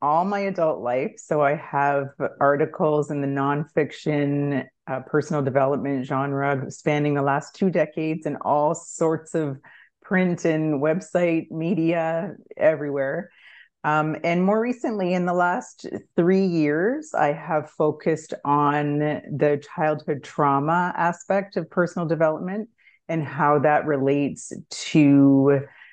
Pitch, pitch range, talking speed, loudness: 155 Hz, 145-175 Hz, 125 wpm, -23 LUFS